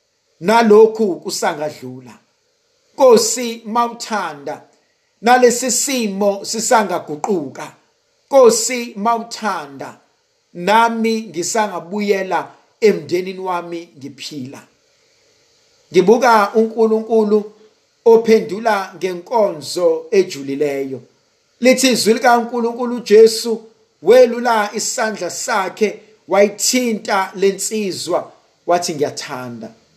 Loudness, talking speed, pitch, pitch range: -16 LUFS, 65 wpm, 220 Hz, 190-240 Hz